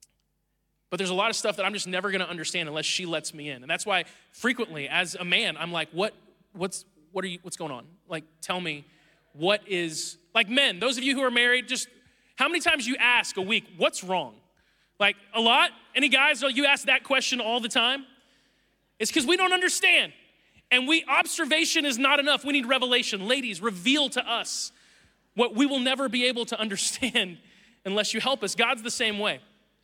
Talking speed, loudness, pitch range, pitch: 210 wpm, -24 LUFS, 185-265 Hz, 225 Hz